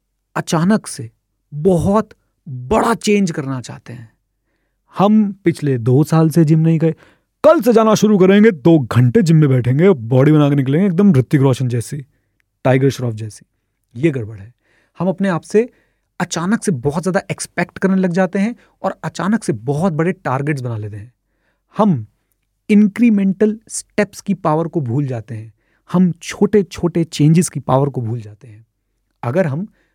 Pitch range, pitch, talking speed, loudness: 120-190 Hz, 155 Hz, 165 wpm, -15 LUFS